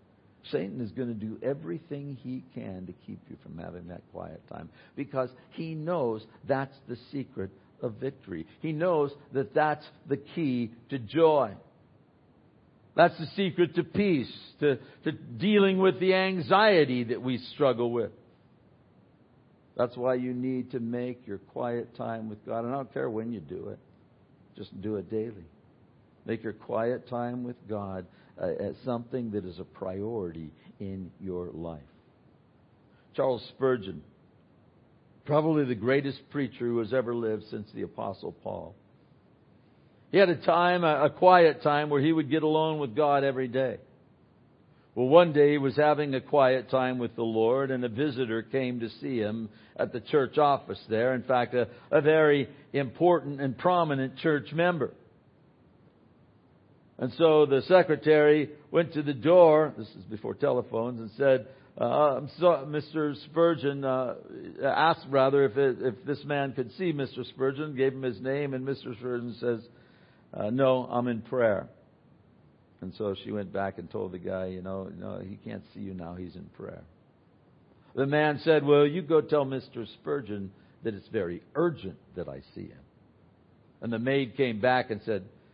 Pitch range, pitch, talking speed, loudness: 115-150 Hz, 130 Hz, 170 wpm, -28 LUFS